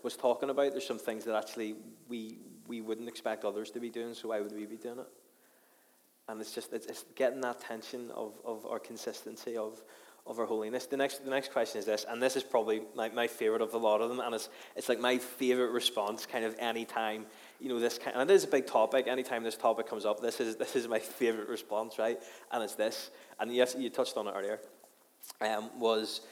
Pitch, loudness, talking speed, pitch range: 115 Hz, -34 LUFS, 235 wpm, 110-125 Hz